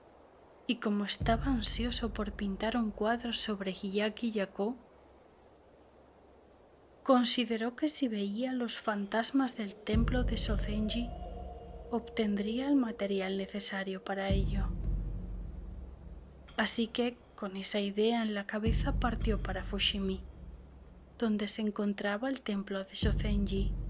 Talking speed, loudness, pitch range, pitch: 115 wpm, -33 LUFS, 190-230 Hz, 210 Hz